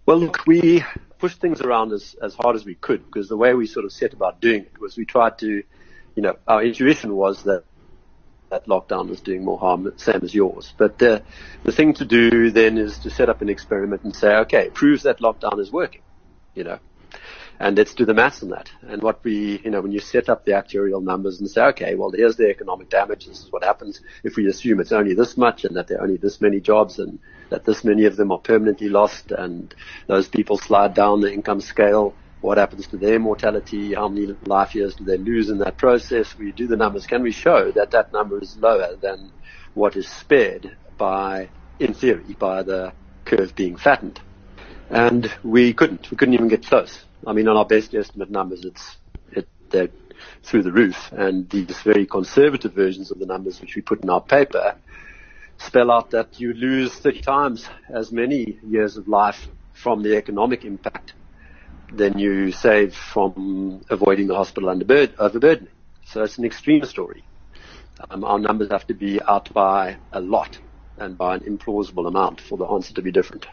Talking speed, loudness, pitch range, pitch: 205 wpm, -19 LUFS, 100-115 Hz, 105 Hz